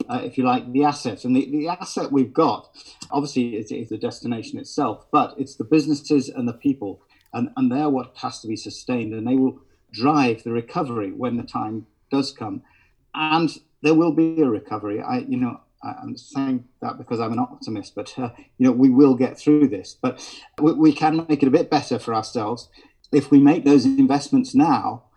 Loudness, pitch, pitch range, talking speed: -21 LUFS, 145 Hz, 130-175 Hz, 205 wpm